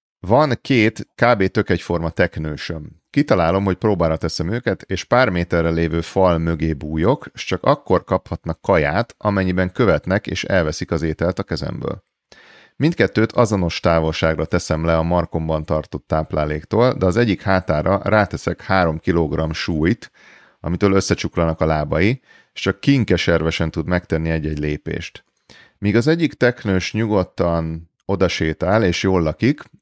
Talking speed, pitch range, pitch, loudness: 135 wpm, 80-100 Hz, 85 Hz, -19 LUFS